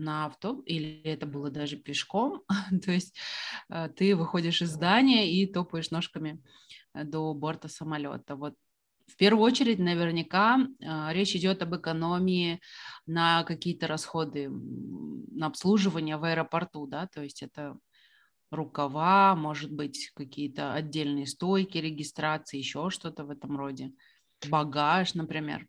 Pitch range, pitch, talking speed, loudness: 150-180 Hz, 160 Hz, 125 wpm, -29 LUFS